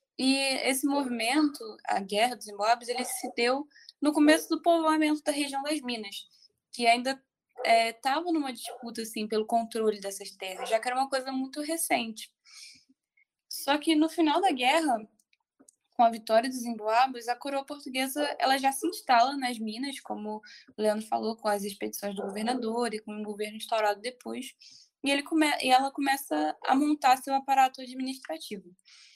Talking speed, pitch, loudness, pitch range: 165 wpm, 255 Hz, -28 LUFS, 225-290 Hz